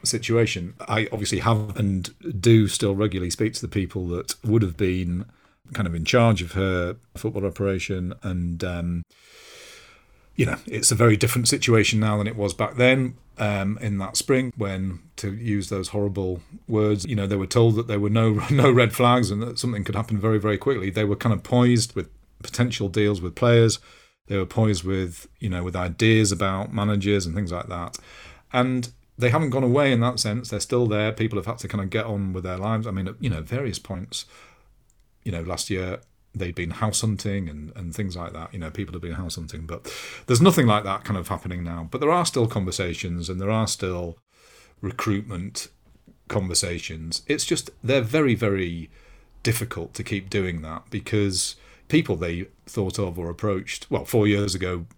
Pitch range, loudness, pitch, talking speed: 95-115 Hz, -24 LUFS, 105 Hz, 200 wpm